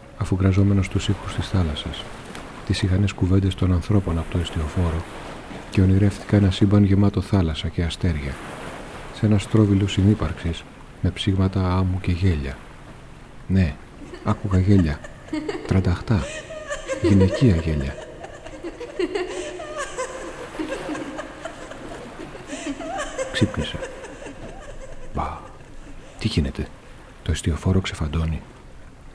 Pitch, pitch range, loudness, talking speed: 95 Hz, 85-110 Hz, -23 LUFS, 90 wpm